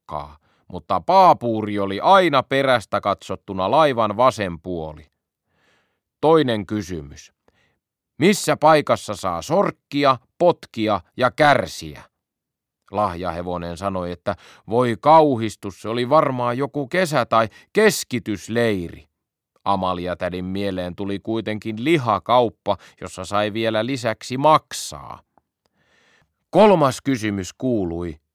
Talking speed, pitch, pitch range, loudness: 95 wpm, 110 Hz, 90-135 Hz, -20 LUFS